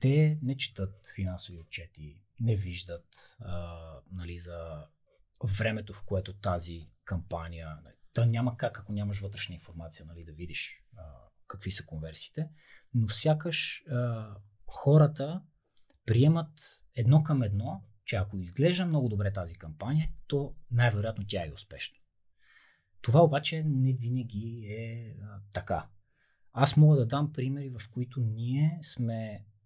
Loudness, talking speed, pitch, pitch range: -30 LUFS, 130 wpm, 110 Hz, 95-135 Hz